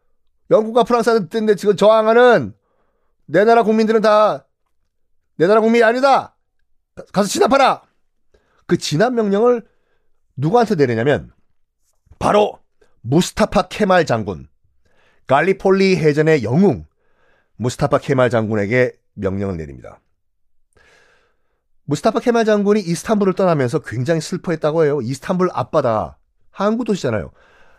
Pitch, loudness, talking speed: 185 Hz, -16 LUFS, 280 characters per minute